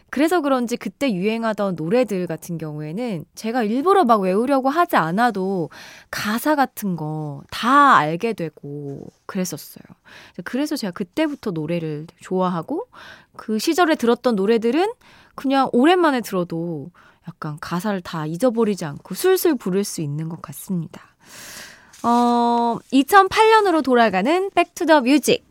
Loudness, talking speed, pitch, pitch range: -20 LUFS, 295 characters per minute, 225 Hz, 170-275 Hz